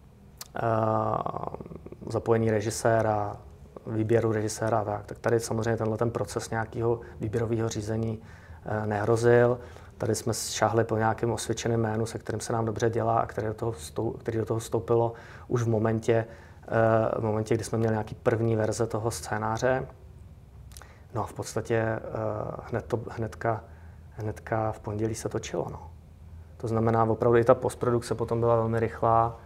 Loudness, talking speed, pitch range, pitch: -28 LUFS, 155 wpm, 105-115 Hz, 110 Hz